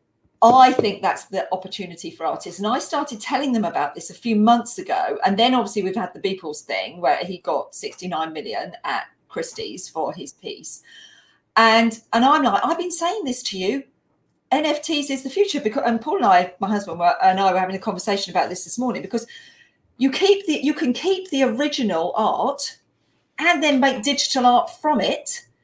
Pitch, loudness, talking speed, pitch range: 245 Hz, -21 LUFS, 200 wpm, 195-305 Hz